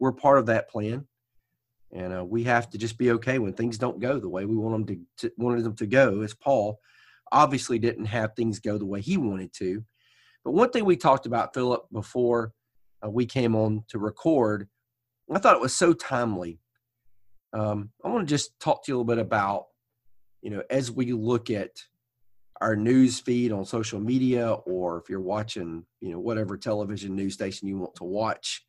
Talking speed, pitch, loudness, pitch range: 205 wpm, 115 Hz, -26 LUFS, 105-120 Hz